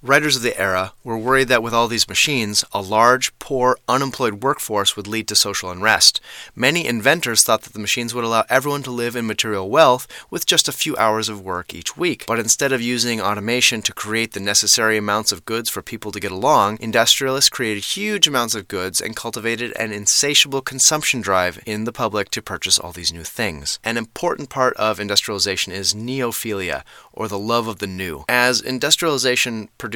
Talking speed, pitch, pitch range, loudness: 195 wpm, 115 Hz, 105-125 Hz, -18 LUFS